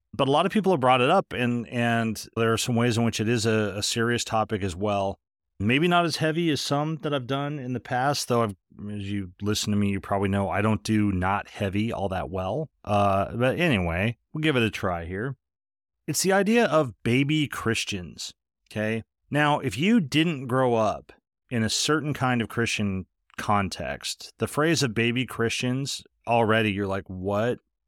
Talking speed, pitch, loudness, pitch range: 200 wpm, 115 Hz, -25 LUFS, 100-140 Hz